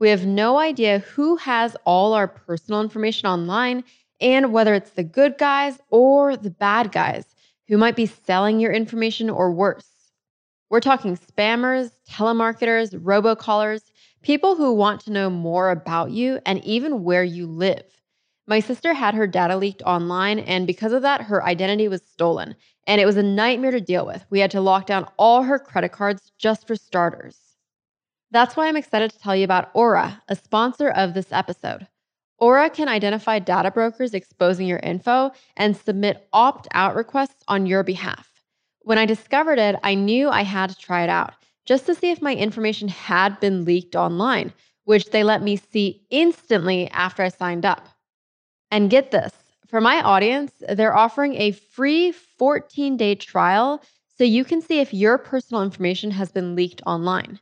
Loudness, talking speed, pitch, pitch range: -20 LUFS, 175 wpm, 215 Hz, 195-245 Hz